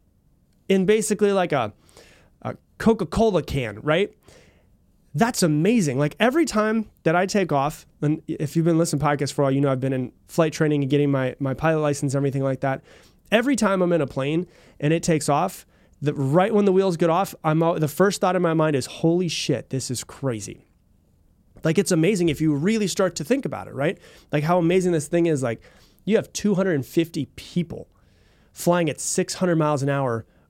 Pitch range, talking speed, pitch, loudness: 140-185 Hz, 205 wpm, 160 Hz, -22 LUFS